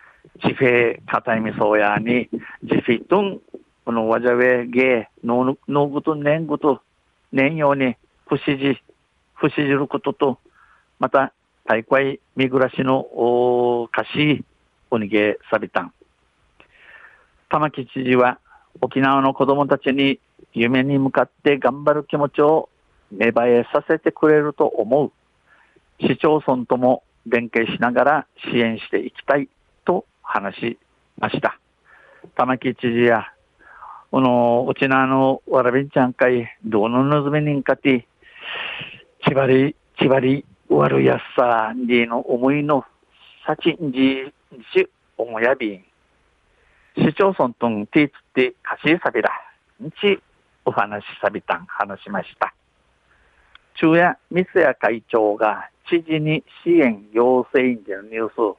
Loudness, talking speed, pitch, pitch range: -19 LUFS, 235 characters per minute, 130 Hz, 120-145 Hz